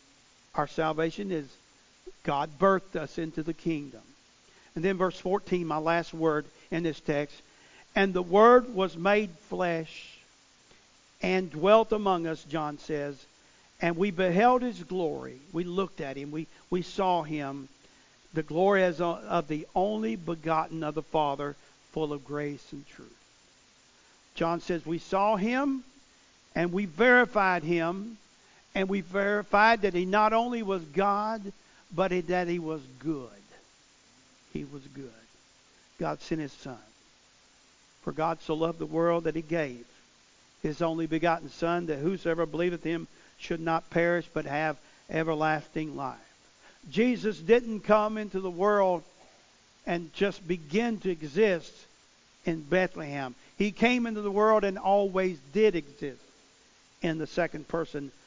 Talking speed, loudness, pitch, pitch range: 145 wpm, -29 LUFS, 170 Hz, 155-195 Hz